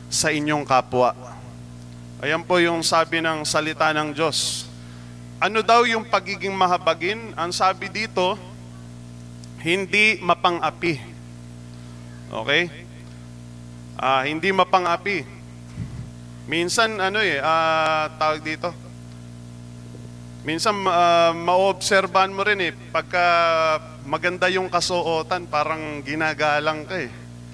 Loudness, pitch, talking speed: -21 LUFS, 155 Hz, 100 wpm